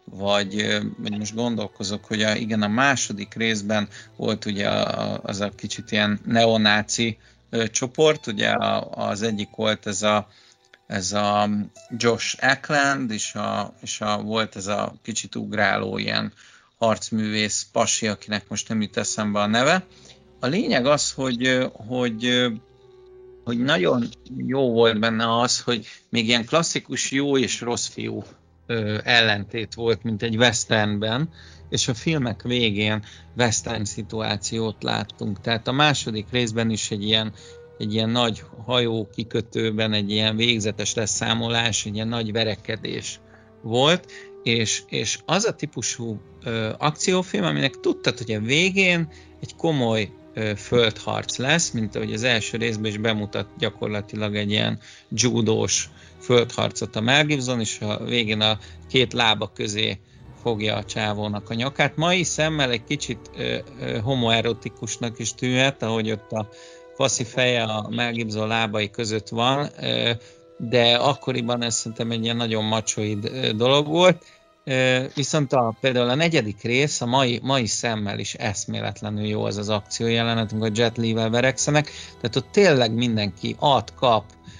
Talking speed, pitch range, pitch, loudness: 150 wpm, 105-125 Hz, 115 Hz, -22 LUFS